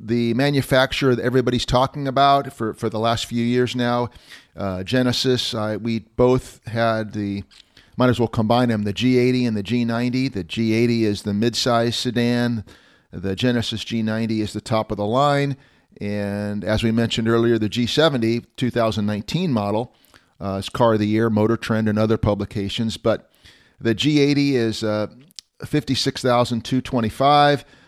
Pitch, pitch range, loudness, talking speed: 115 Hz, 110-125 Hz, -20 LUFS, 155 wpm